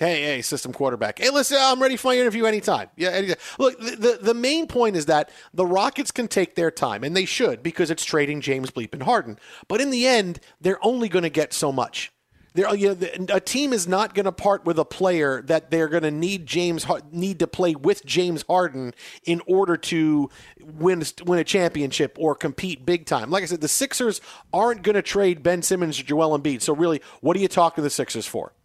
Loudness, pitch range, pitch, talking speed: -22 LUFS, 155-200 Hz, 175 Hz, 230 wpm